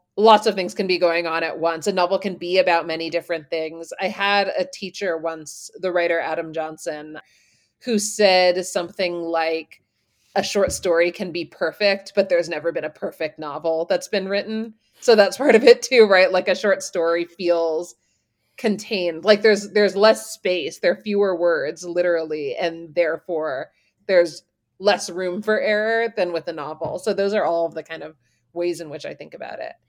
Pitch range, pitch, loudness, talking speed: 165-200 Hz, 175 Hz, -20 LUFS, 190 wpm